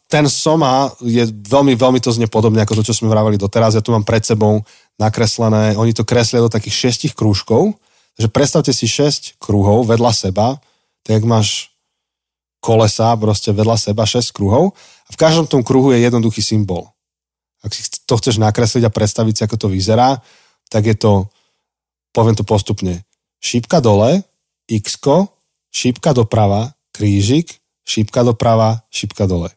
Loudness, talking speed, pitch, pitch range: -14 LUFS, 155 wpm, 115 Hz, 105-125 Hz